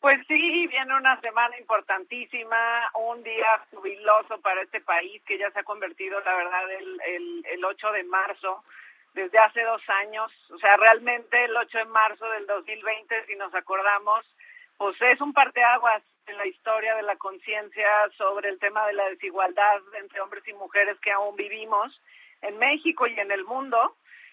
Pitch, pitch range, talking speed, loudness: 215 Hz, 200-230 Hz, 170 wpm, -24 LUFS